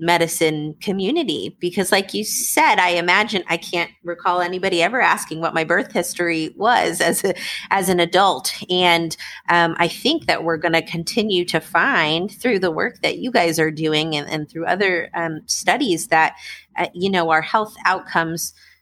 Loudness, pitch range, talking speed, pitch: -19 LUFS, 165-195 Hz, 175 wpm, 175 Hz